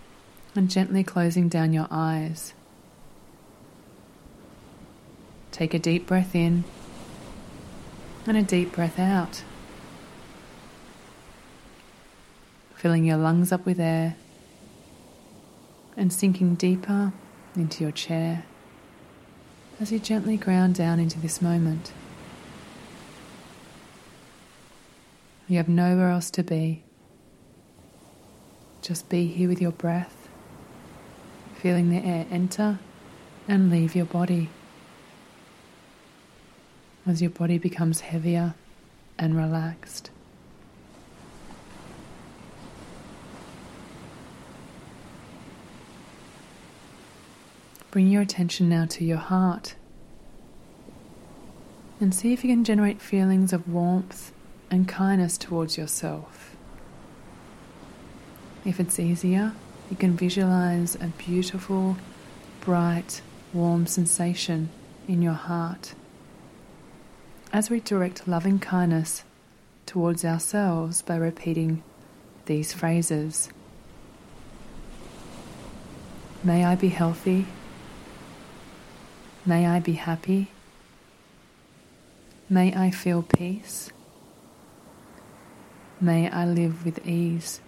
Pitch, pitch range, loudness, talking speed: 175 Hz, 165-185 Hz, -25 LUFS, 85 wpm